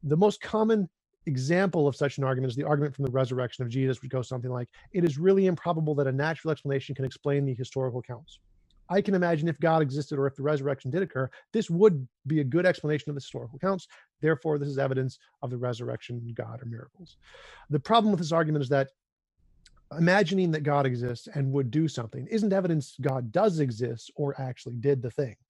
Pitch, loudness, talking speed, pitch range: 140 Hz, -28 LUFS, 210 wpm, 130-165 Hz